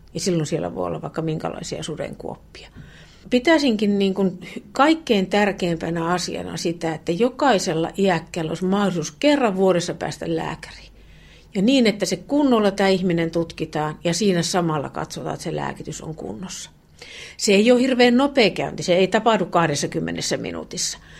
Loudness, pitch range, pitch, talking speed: -21 LUFS, 165-225 Hz, 185 Hz, 145 wpm